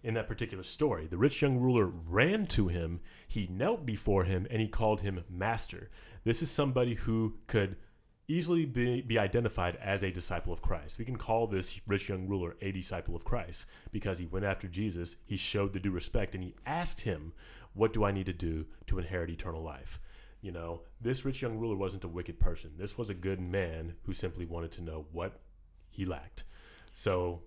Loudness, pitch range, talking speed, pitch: -34 LUFS, 85-110 Hz, 205 wpm, 95 Hz